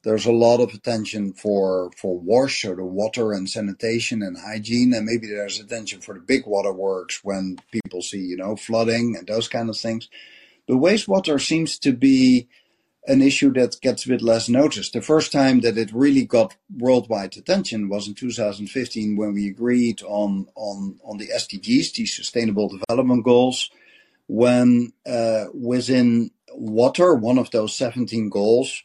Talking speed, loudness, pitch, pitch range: 170 wpm, -21 LUFS, 115 Hz, 105-125 Hz